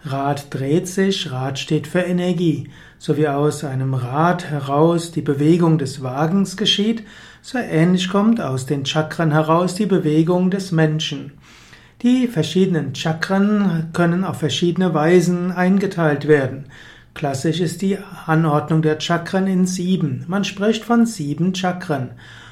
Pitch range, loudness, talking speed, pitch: 150-185 Hz, -19 LUFS, 135 wpm, 165 Hz